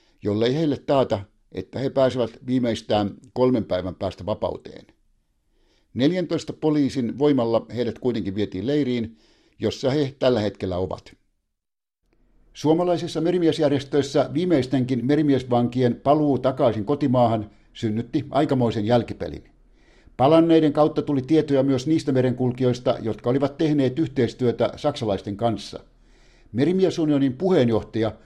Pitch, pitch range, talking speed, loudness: 125 Hz, 110-145 Hz, 100 wpm, -22 LUFS